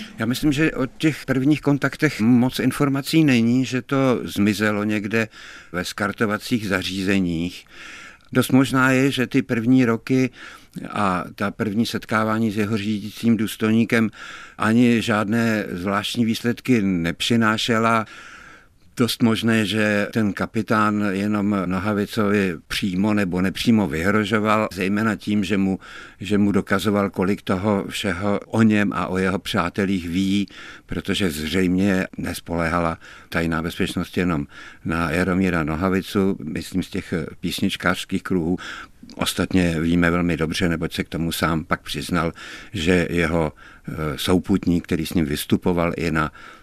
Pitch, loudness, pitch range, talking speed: 100 Hz, -21 LUFS, 90-115 Hz, 125 wpm